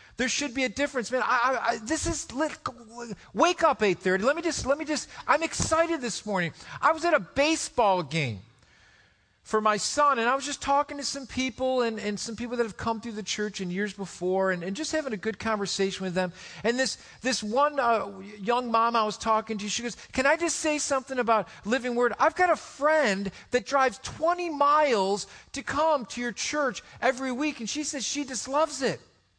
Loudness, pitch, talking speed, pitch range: -27 LUFS, 245 Hz, 215 wpm, 210-285 Hz